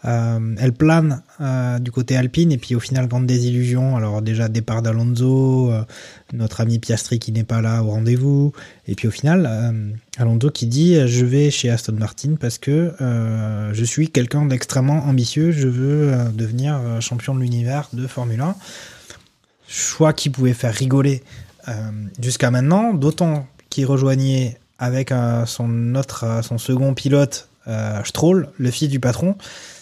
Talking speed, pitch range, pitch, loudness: 175 wpm, 115-140 Hz, 125 Hz, -19 LUFS